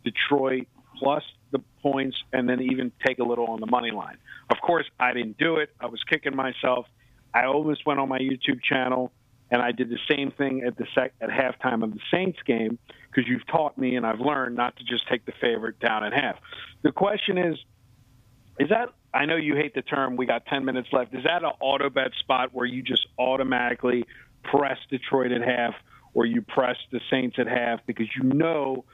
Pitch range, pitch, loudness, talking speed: 120-140 Hz, 130 Hz, -26 LUFS, 210 wpm